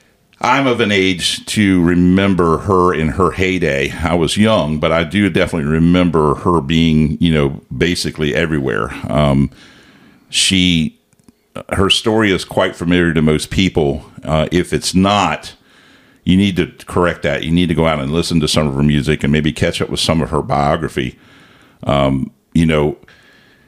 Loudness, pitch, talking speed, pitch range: -15 LUFS, 80 Hz, 170 wpm, 75-90 Hz